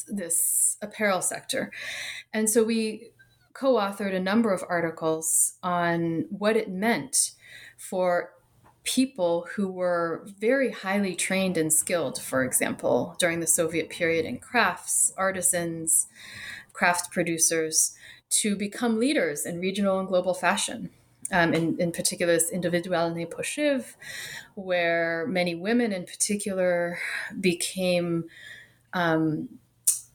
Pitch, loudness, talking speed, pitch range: 180 Hz, -25 LUFS, 115 wpm, 170-205 Hz